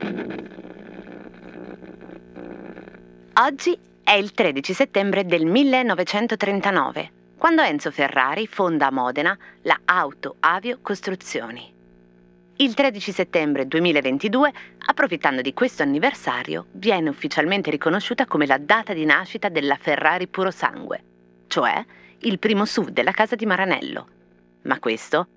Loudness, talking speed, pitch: -21 LUFS, 110 wpm, 165 Hz